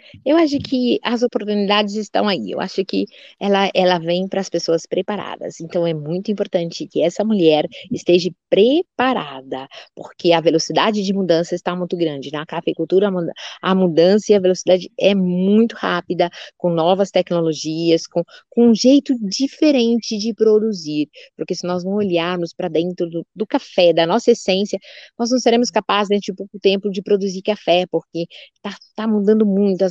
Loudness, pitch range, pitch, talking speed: -18 LUFS, 170-215 Hz, 190 Hz, 175 wpm